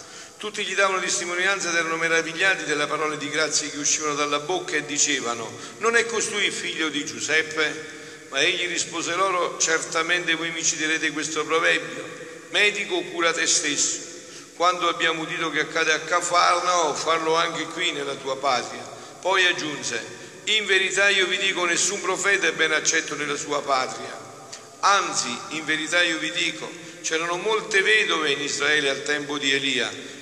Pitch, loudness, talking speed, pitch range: 165 Hz, -22 LUFS, 160 wpm, 155-175 Hz